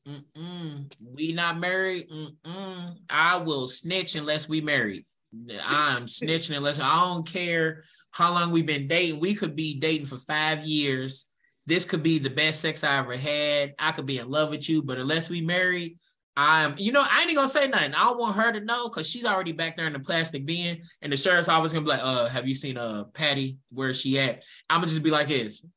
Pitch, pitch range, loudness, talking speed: 160 Hz, 145-170 Hz, -25 LUFS, 225 wpm